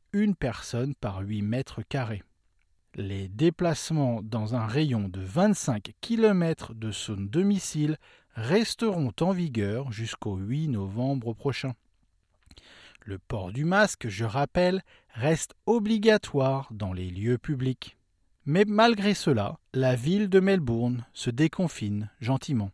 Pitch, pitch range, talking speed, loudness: 130 Hz, 105-165 Hz, 120 wpm, -27 LUFS